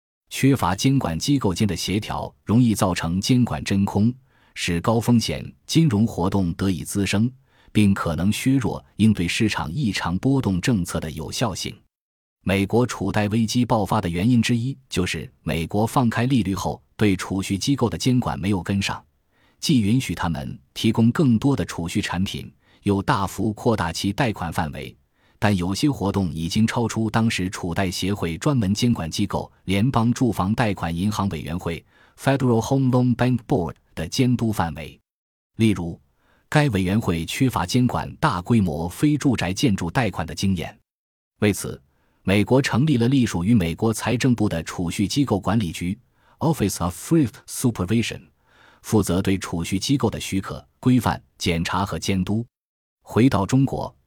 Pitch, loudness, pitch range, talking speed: 105 Hz, -22 LUFS, 90-120 Hz, 290 characters per minute